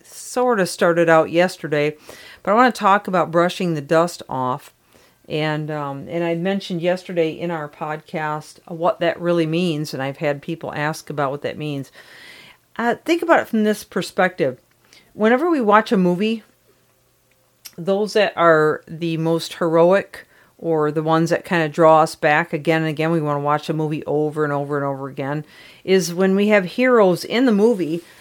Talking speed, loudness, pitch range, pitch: 185 wpm, -19 LUFS, 155-195 Hz, 165 Hz